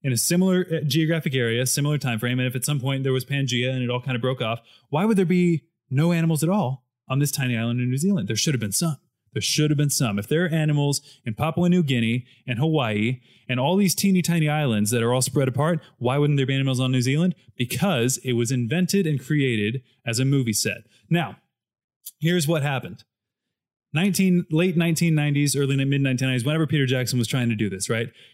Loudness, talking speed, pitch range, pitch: -23 LUFS, 225 wpm, 125-160 Hz, 135 Hz